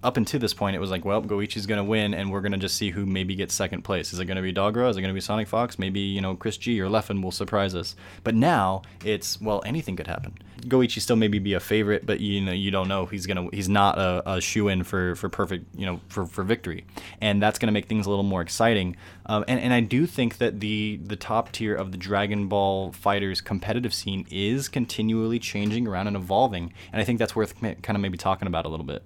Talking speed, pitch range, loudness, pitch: 255 wpm, 95-110 Hz, -26 LUFS, 100 Hz